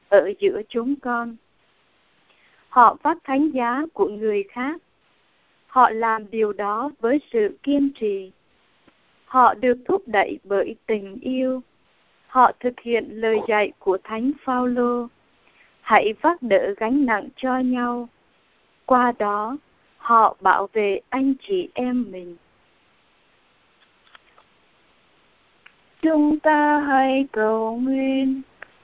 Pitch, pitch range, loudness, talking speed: 250 Hz, 220-280 Hz, -21 LUFS, 115 wpm